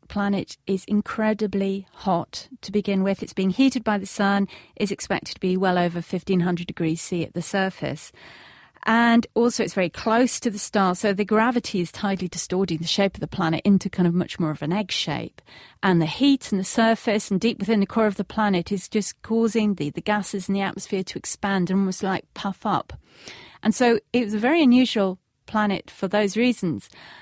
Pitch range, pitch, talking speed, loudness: 180-220 Hz, 200 Hz, 210 wpm, -23 LUFS